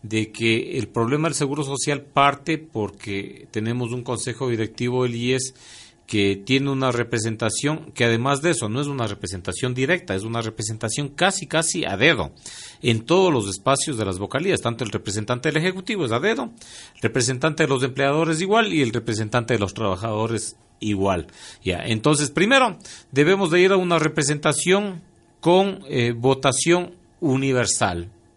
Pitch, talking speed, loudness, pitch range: 130 Hz, 160 wpm, -22 LUFS, 110-155 Hz